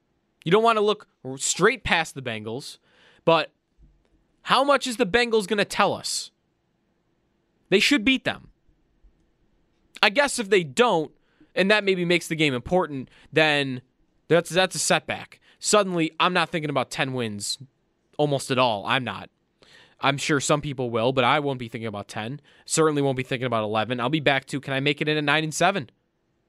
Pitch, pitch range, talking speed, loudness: 150 Hz, 130-185 Hz, 190 wpm, -23 LUFS